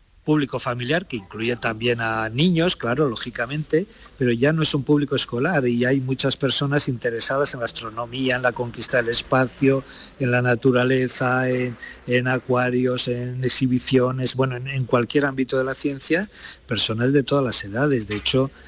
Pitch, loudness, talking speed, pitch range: 130 Hz, -22 LUFS, 165 wpm, 120-140 Hz